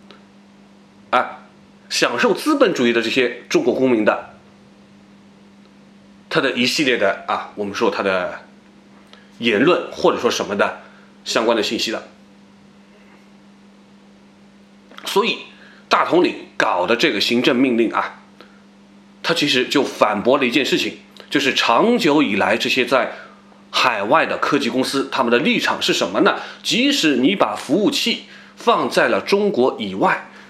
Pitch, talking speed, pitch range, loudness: 100 Hz, 205 characters per minute, 100-130 Hz, -18 LUFS